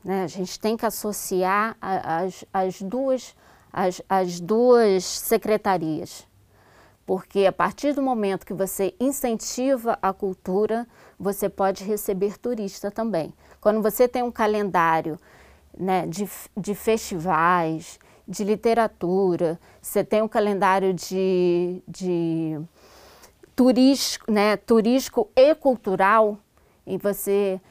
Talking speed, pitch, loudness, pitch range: 110 wpm, 200 Hz, -23 LUFS, 185-220 Hz